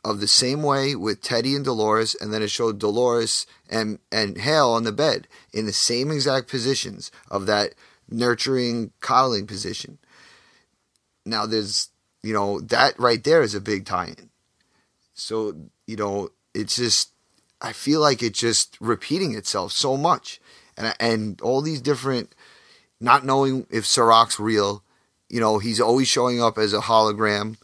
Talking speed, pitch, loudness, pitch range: 160 wpm, 115 Hz, -21 LUFS, 105-130 Hz